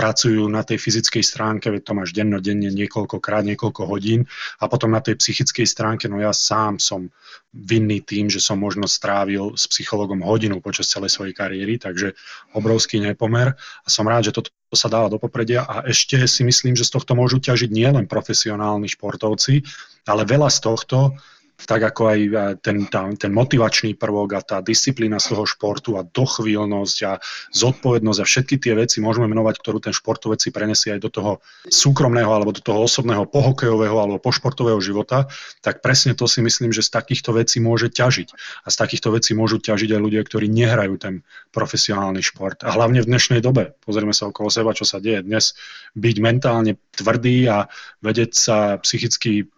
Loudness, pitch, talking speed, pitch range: -18 LUFS, 110 Hz, 180 wpm, 105-120 Hz